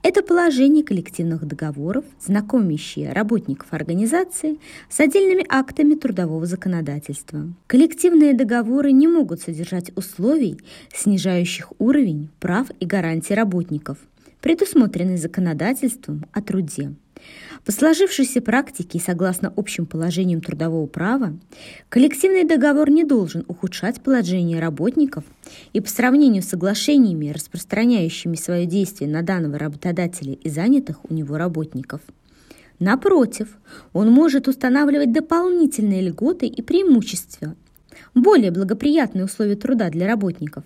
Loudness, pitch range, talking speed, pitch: -19 LUFS, 170-270 Hz, 110 wpm, 200 Hz